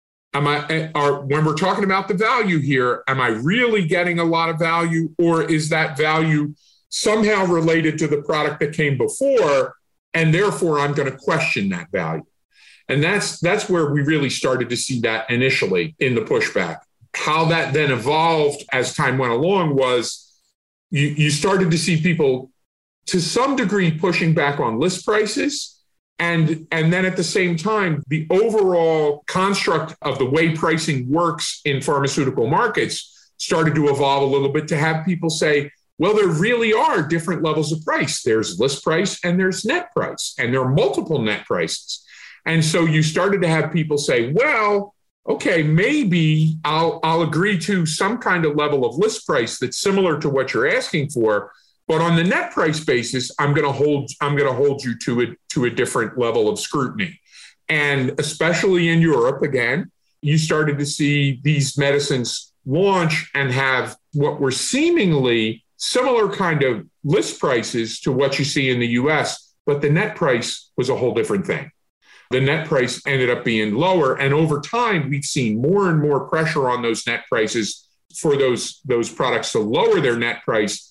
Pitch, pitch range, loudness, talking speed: 155 Hz, 140-175 Hz, -19 LUFS, 180 wpm